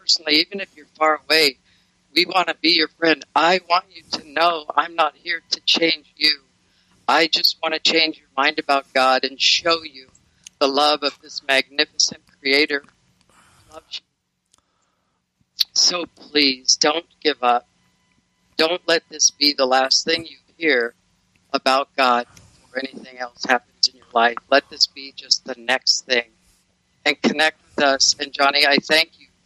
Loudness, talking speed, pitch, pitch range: -18 LUFS, 170 wpm, 145 Hz, 130-160 Hz